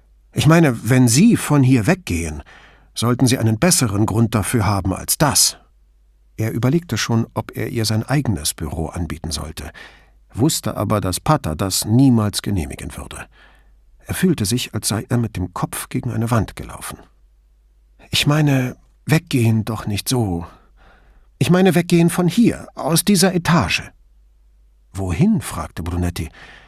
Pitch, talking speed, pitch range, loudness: 110 Hz, 145 wpm, 80-130 Hz, -18 LUFS